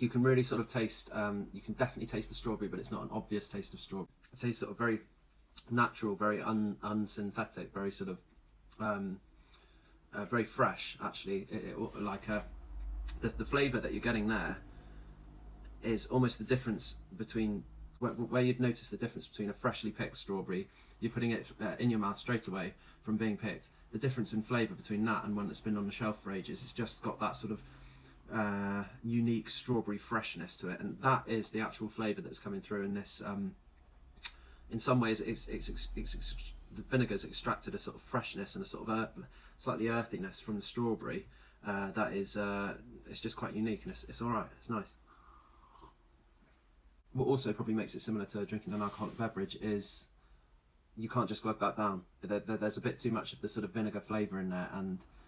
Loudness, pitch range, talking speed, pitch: -37 LUFS, 100-115 Hz, 205 wpm, 105 Hz